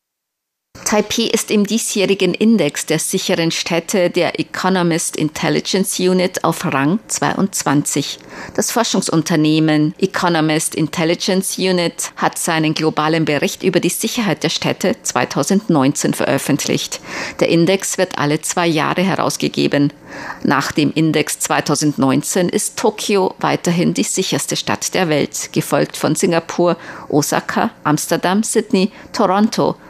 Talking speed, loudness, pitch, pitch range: 115 wpm, -16 LUFS, 175 Hz, 155-195 Hz